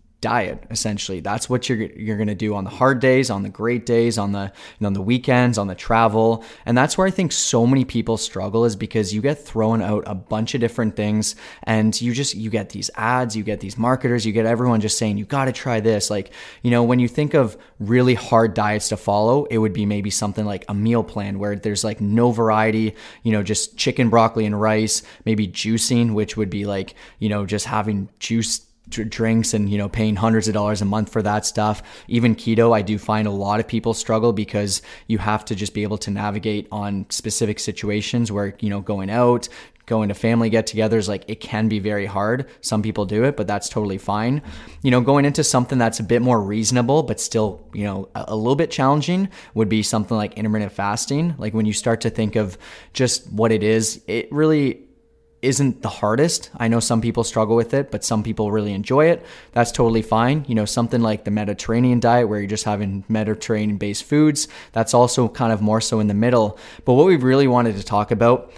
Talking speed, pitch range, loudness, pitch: 220 wpm, 105-120 Hz, -20 LUFS, 110 Hz